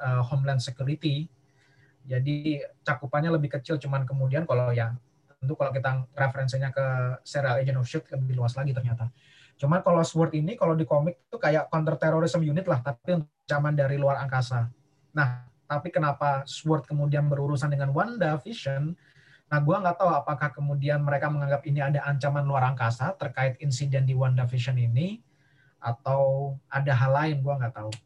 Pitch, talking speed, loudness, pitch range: 140 Hz, 165 wpm, -27 LUFS, 135-150 Hz